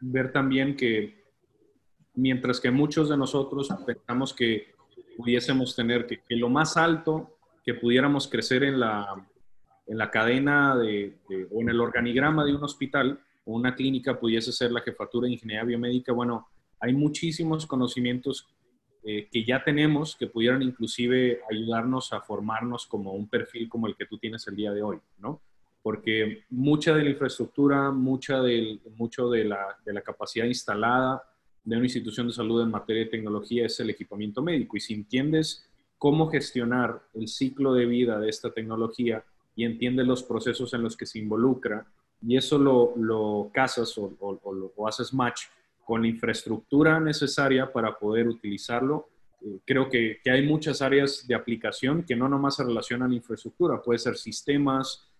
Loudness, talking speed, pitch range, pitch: -27 LUFS, 165 wpm, 115-135 Hz, 120 Hz